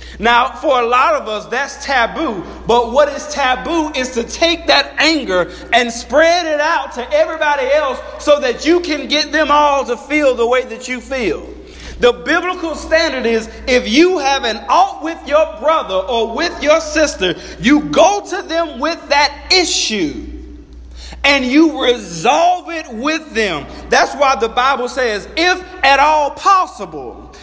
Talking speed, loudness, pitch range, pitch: 165 wpm, -14 LUFS, 250-320 Hz, 290 Hz